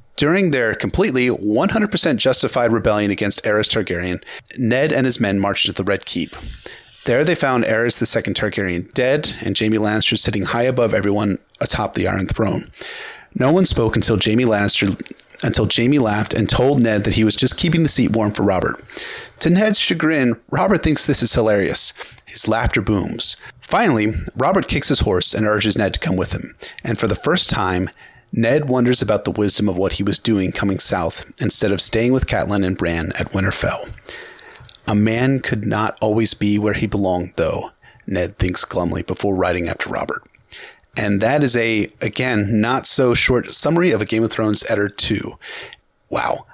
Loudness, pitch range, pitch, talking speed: -17 LUFS, 100-125 Hz, 110 Hz, 180 wpm